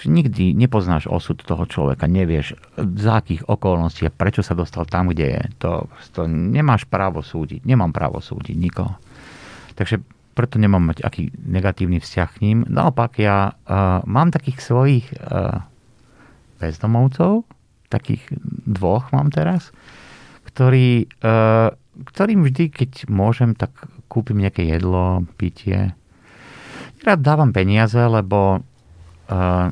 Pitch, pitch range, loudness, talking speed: 105 Hz, 90-130 Hz, -19 LUFS, 125 wpm